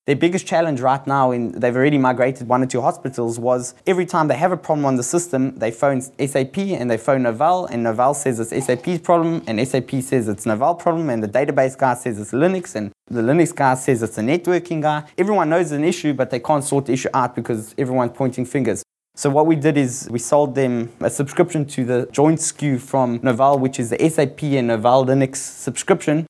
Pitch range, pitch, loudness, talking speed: 125-155 Hz, 135 Hz, -19 LUFS, 220 wpm